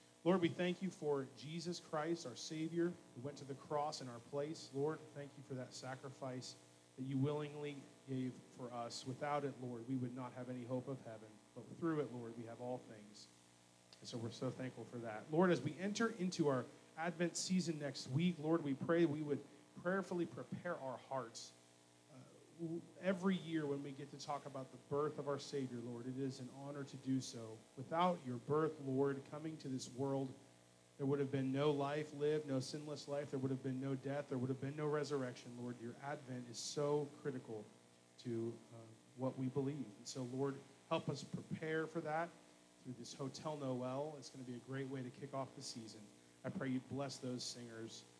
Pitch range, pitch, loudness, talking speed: 125-150 Hz, 135 Hz, -44 LUFS, 205 wpm